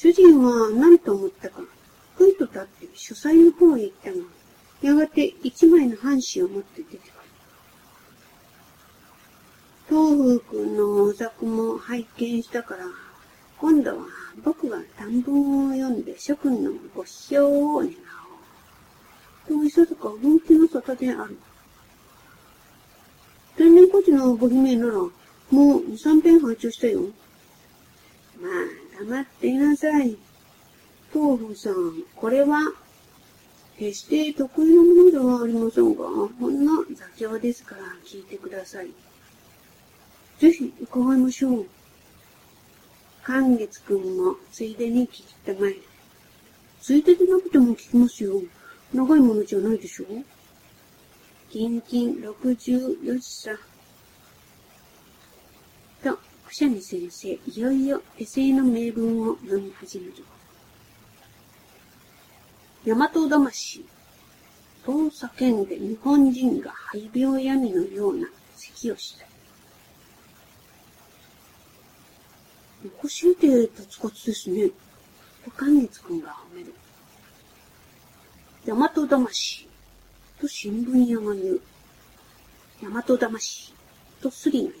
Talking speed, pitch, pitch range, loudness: 200 characters per minute, 270 Hz, 230-325 Hz, -21 LUFS